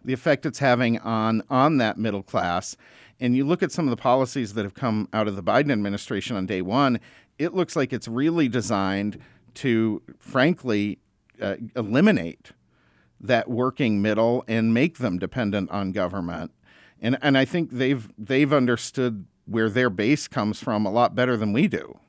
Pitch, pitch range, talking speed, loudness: 115 Hz, 105-130 Hz, 175 wpm, -24 LUFS